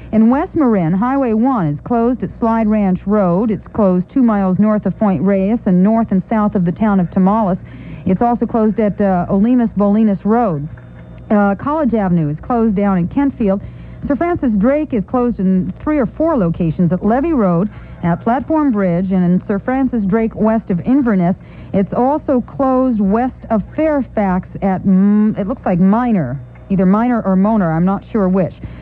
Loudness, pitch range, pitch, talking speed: -15 LUFS, 190-235 Hz, 210 Hz, 185 wpm